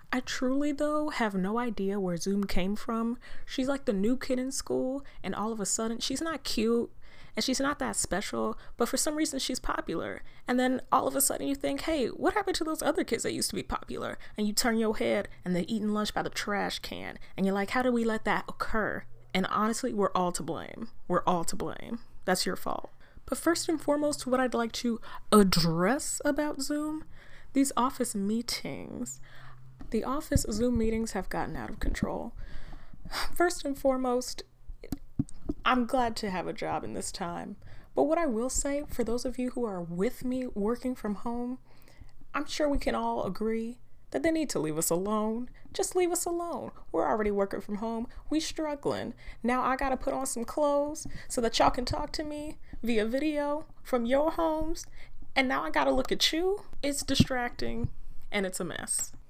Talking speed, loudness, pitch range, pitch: 200 wpm, -31 LUFS, 210-285 Hz, 245 Hz